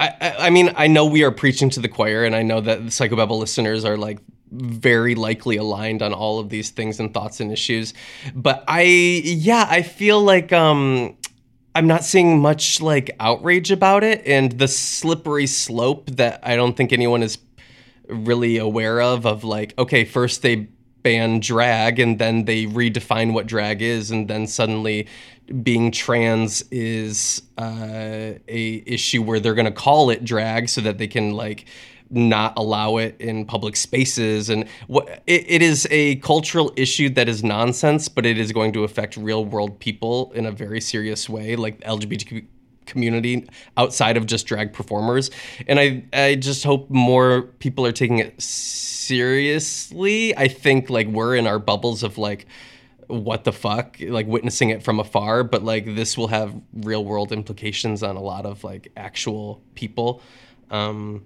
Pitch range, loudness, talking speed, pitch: 110-130 Hz, -19 LUFS, 175 wpm, 115 Hz